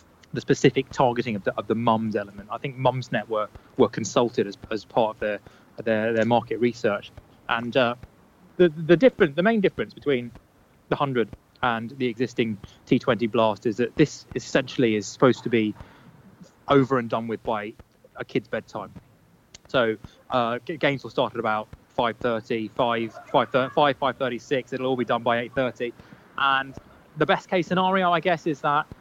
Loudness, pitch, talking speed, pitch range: -24 LUFS, 120 Hz, 175 wpm, 110-135 Hz